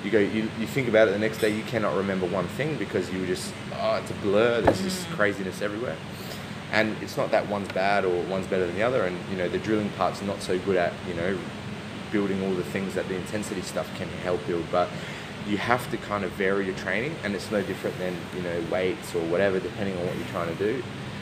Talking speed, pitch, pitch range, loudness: 250 wpm, 100 Hz, 95-110 Hz, -27 LUFS